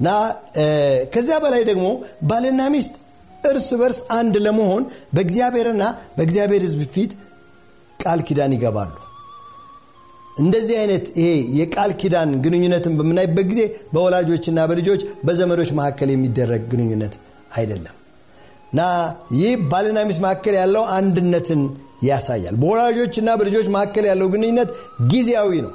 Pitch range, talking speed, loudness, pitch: 145-220 Hz, 110 wpm, -19 LUFS, 185 Hz